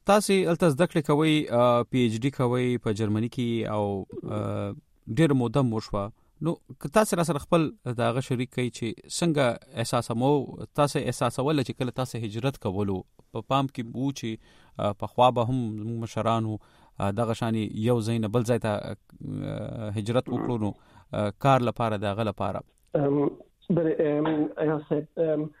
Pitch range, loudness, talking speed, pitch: 110-145 Hz, -27 LUFS, 150 wpm, 125 Hz